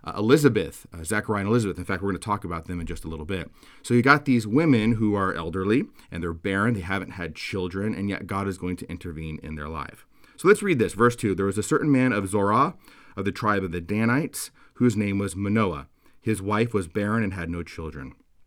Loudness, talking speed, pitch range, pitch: -25 LUFS, 245 wpm, 85-110 Hz, 100 Hz